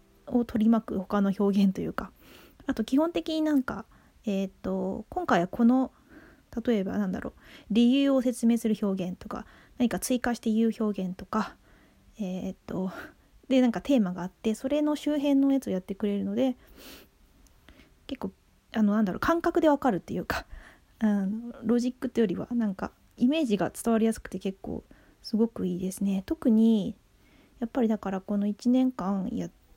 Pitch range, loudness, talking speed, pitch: 195-255 Hz, -28 LUFS, 335 characters per minute, 225 Hz